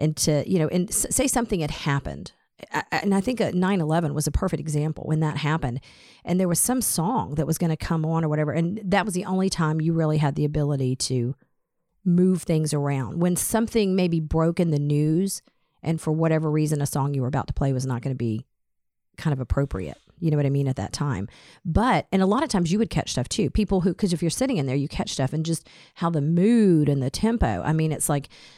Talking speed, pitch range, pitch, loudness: 250 wpm, 145-180 Hz, 160 Hz, -24 LUFS